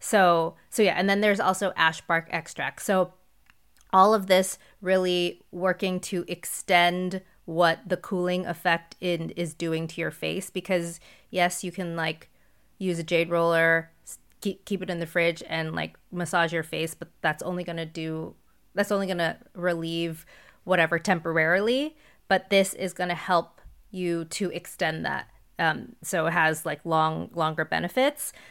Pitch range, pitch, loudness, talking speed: 165-185 Hz, 175 Hz, -26 LUFS, 160 wpm